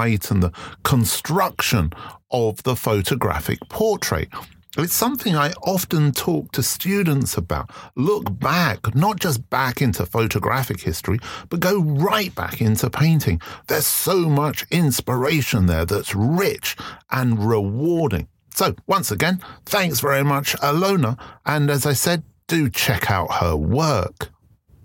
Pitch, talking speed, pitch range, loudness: 135 Hz, 130 wpm, 110-160 Hz, -20 LUFS